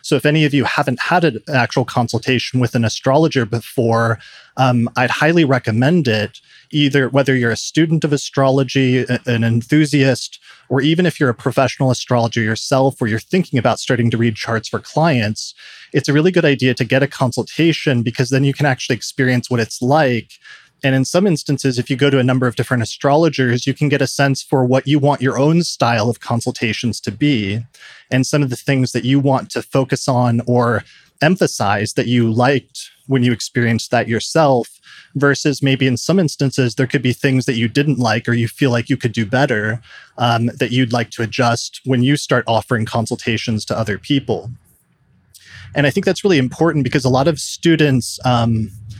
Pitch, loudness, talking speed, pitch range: 130 Hz, -16 LUFS, 195 wpm, 120-140 Hz